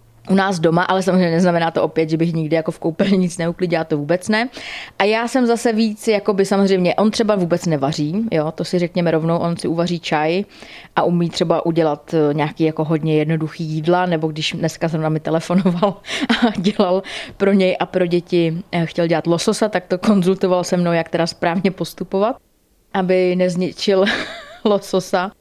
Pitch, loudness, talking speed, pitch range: 180 Hz, -18 LUFS, 185 wpm, 165-195 Hz